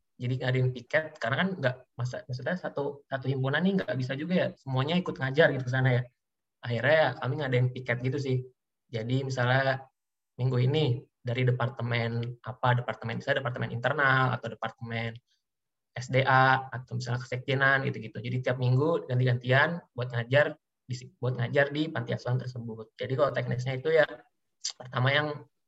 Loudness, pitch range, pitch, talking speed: -29 LUFS, 120-135 Hz, 130 Hz, 170 wpm